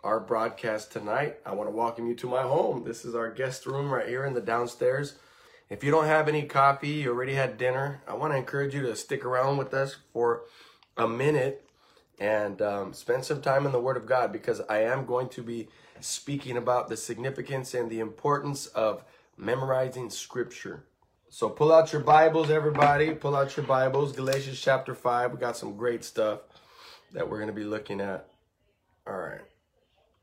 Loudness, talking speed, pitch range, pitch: -28 LUFS, 190 wpm, 115-140 Hz, 130 Hz